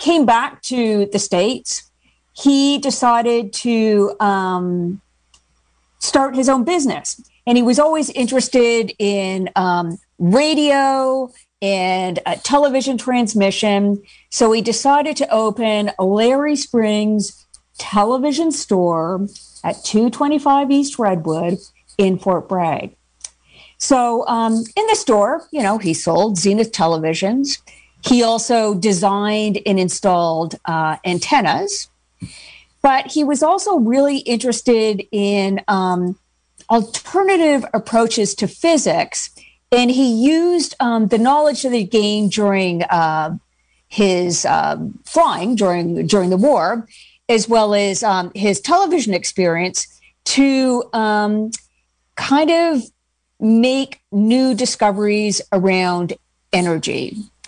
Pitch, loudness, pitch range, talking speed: 225 Hz, -16 LUFS, 195-265 Hz, 110 wpm